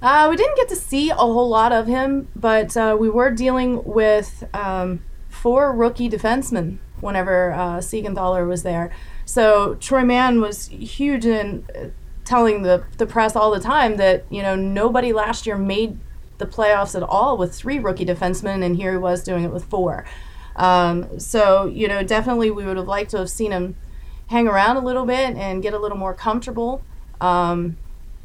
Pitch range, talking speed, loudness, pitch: 185-240 Hz, 185 wpm, -19 LUFS, 210 Hz